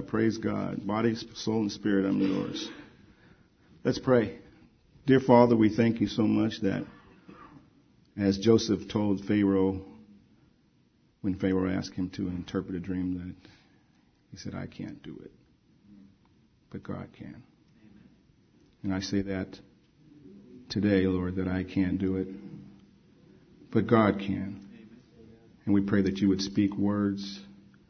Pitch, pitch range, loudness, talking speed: 100 Hz, 95-105 Hz, -28 LUFS, 135 wpm